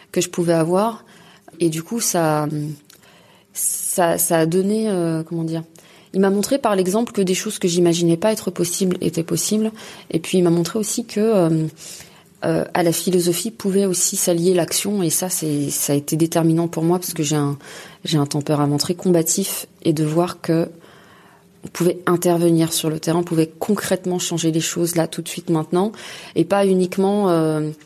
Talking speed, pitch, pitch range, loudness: 190 wpm, 175 Hz, 165-195 Hz, -19 LUFS